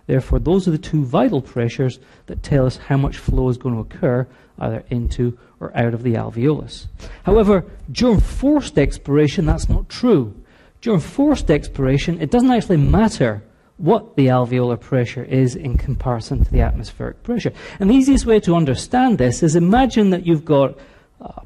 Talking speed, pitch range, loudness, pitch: 175 wpm, 125-180 Hz, -18 LUFS, 140 Hz